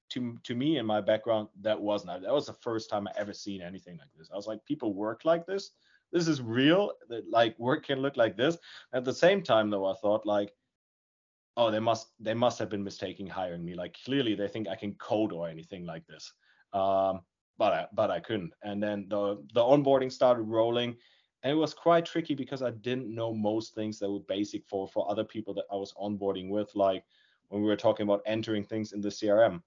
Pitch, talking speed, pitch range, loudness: 110 Hz, 225 wpm, 100-125 Hz, -30 LUFS